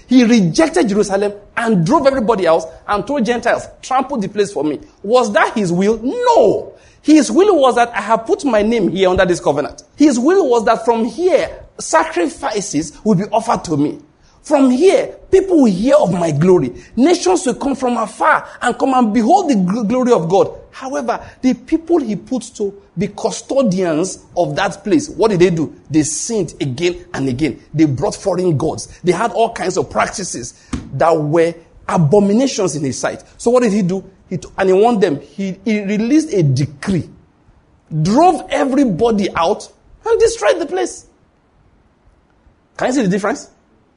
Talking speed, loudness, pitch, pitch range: 180 wpm, -15 LUFS, 225 Hz, 180-270 Hz